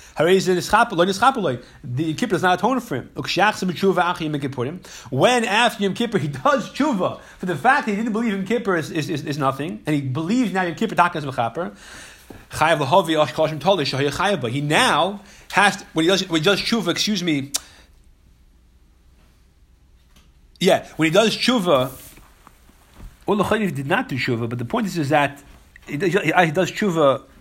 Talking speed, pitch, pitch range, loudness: 155 wpm, 160 Hz, 130-195 Hz, -20 LUFS